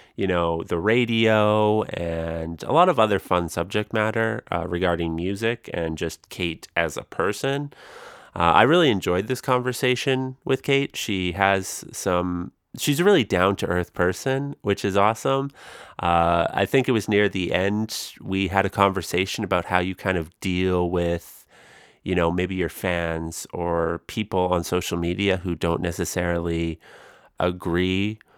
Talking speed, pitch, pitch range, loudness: 160 wpm, 95 Hz, 85-110 Hz, -23 LUFS